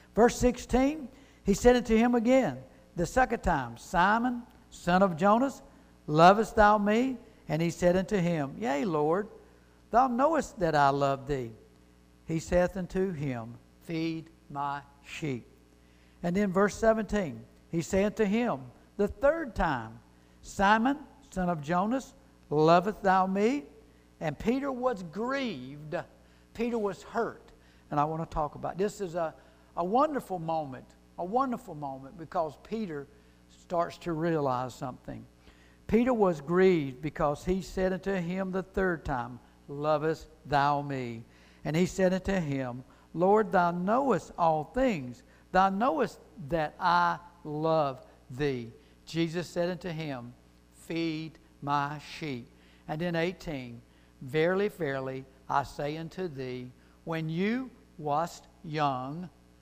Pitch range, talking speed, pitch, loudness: 140-205 Hz, 135 wpm, 170 Hz, -29 LUFS